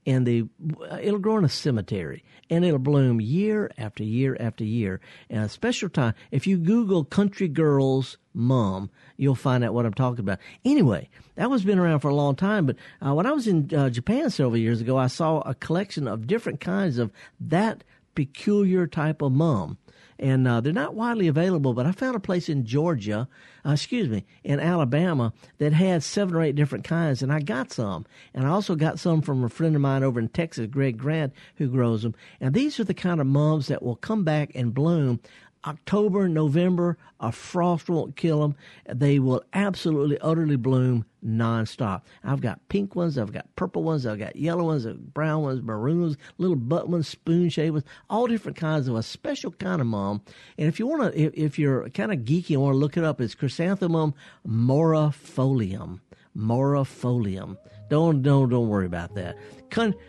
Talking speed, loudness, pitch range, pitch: 195 wpm, -25 LUFS, 125-170 Hz, 150 Hz